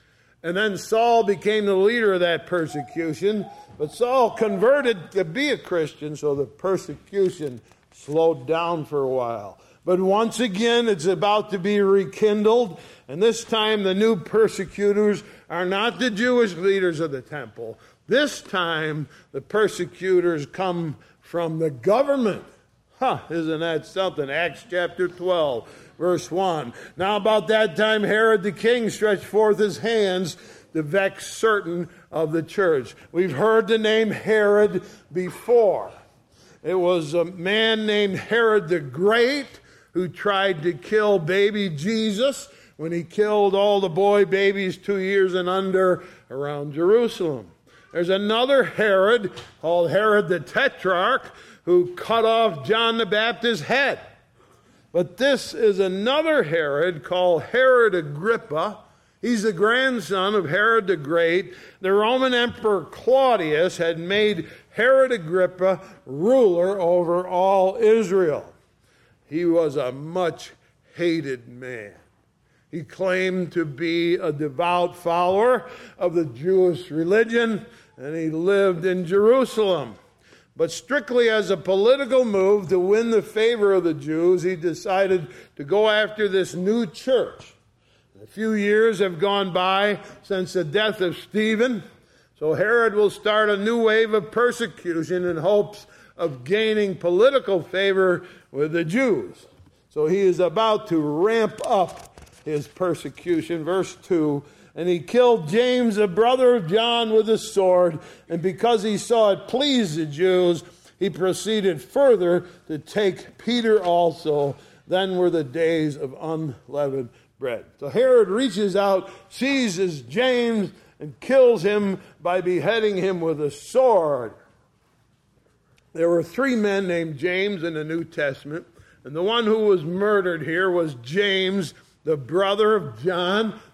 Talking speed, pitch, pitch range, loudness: 140 wpm, 190 Hz, 170-215 Hz, -21 LUFS